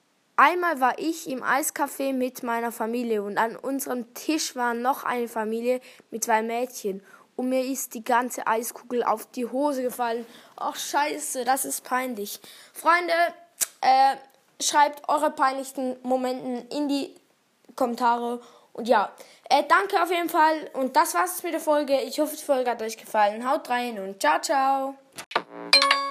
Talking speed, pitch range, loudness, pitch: 155 wpm, 235-290 Hz, -25 LUFS, 260 Hz